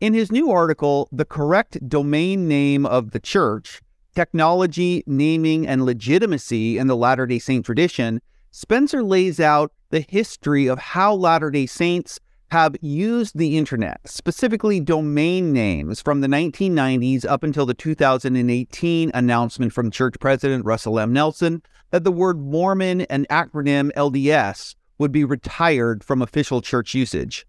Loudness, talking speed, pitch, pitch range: -20 LUFS, 145 wpm, 150 Hz, 130-170 Hz